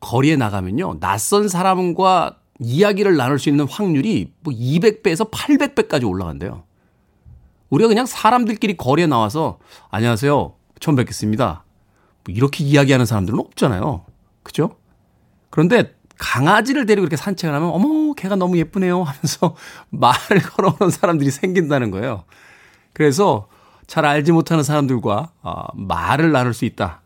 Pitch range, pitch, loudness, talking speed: 120-190 Hz, 150 Hz, -17 LUFS, 335 characters per minute